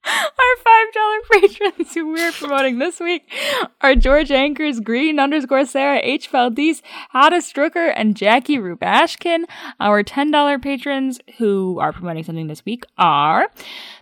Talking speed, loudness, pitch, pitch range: 145 wpm, -17 LUFS, 280 Hz, 250-330 Hz